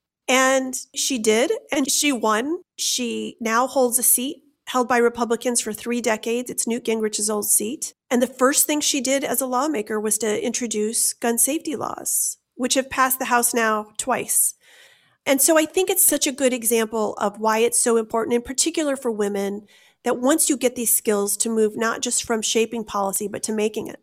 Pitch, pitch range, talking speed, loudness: 240 Hz, 220-270 Hz, 195 wpm, -20 LUFS